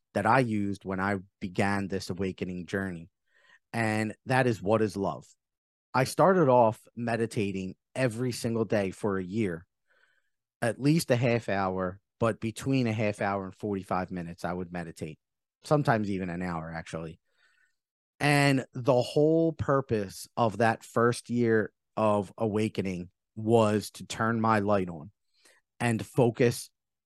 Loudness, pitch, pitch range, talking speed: -28 LUFS, 105 Hz, 95-120 Hz, 140 wpm